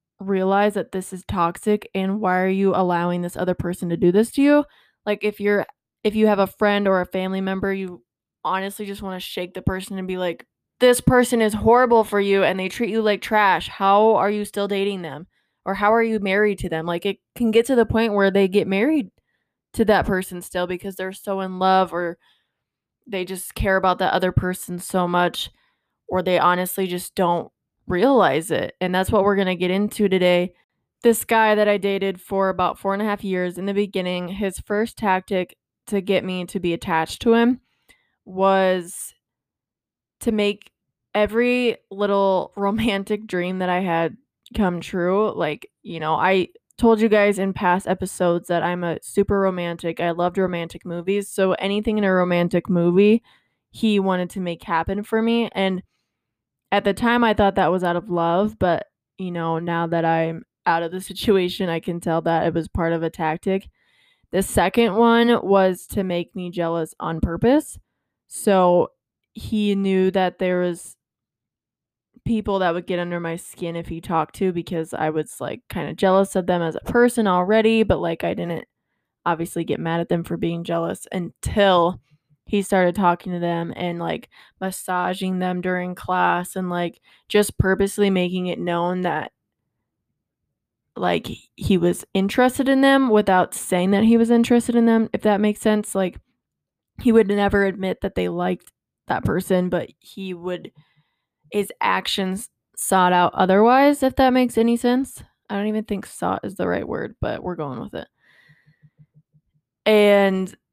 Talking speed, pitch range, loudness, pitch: 185 wpm, 175-205 Hz, -21 LUFS, 190 Hz